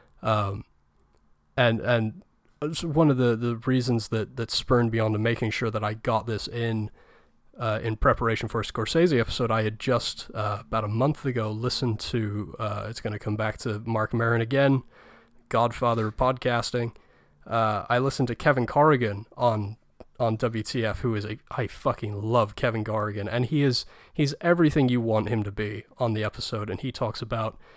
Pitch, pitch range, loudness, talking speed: 115 Hz, 110-125 Hz, -26 LUFS, 180 wpm